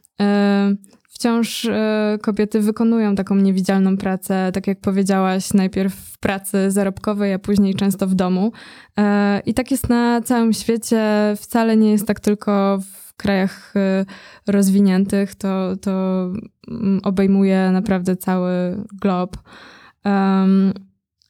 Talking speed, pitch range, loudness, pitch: 110 wpm, 195-210 Hz, -18 LUFS, 200 Hz